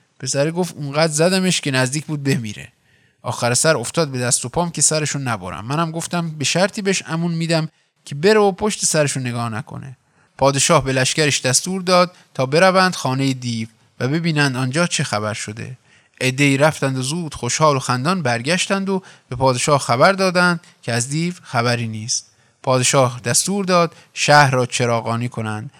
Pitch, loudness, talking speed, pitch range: 145 Hz, -18 LUFS, 165 wpm, 125-170 Hz